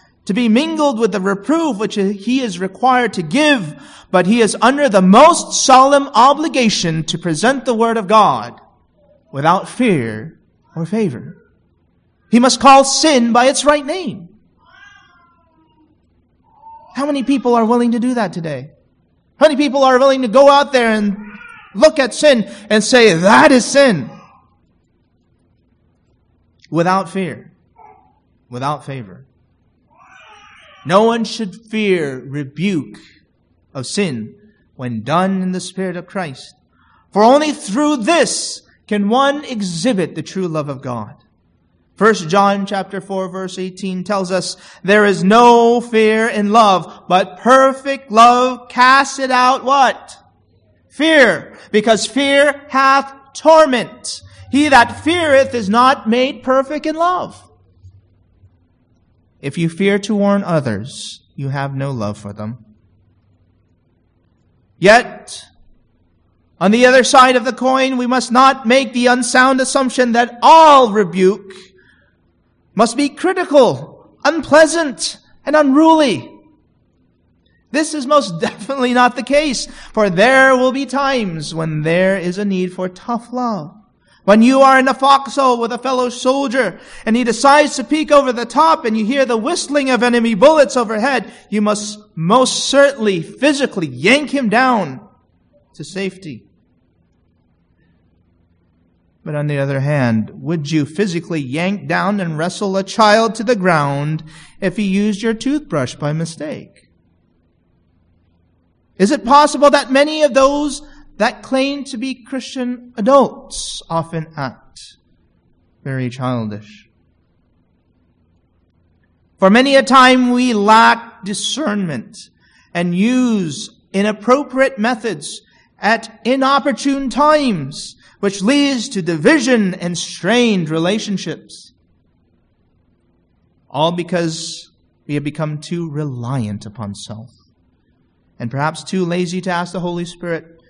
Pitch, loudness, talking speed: 205 Hz, -14 LUFS, 130 wpm